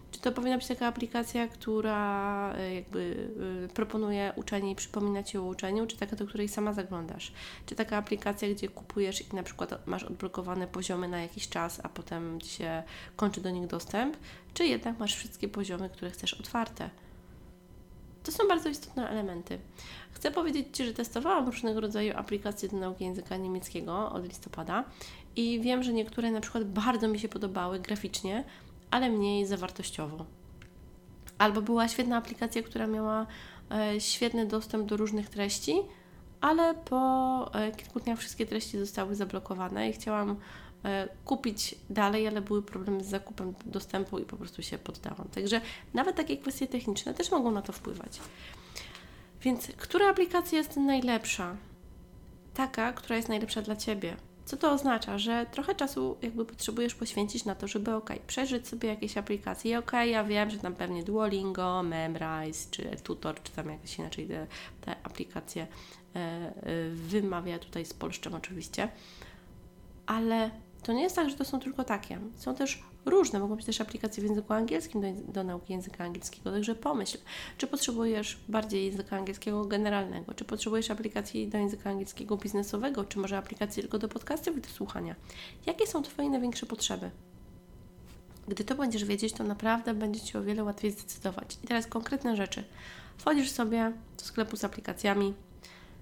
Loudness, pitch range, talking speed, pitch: -33 LUFS, 195-235 Hz, 160 wpm, 215 Hz